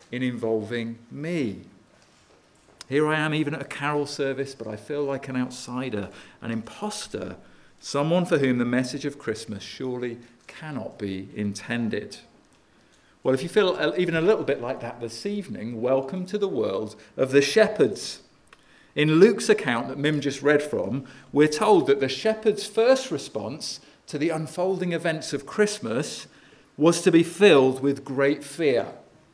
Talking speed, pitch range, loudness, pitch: 155 wpm, 125-165 Hz, -25 LUFS, 140 Hz